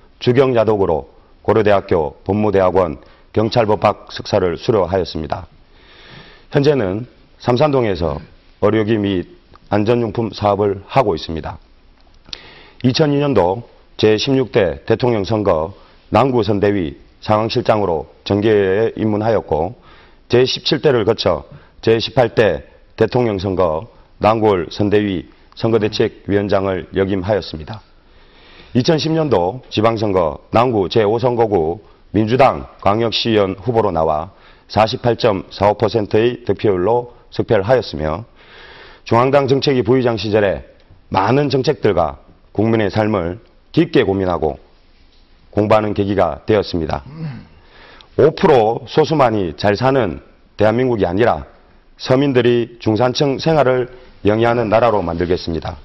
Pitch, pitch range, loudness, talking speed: 110 Hz, 95-120 Hz, -16 LUFS, 250 characters per minute